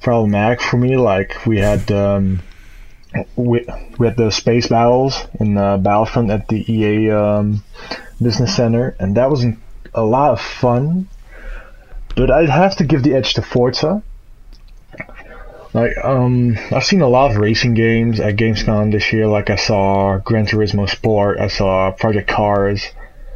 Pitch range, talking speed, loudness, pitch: 100-125 Hz, 160 wpm, -15 LUFS, 110 Hz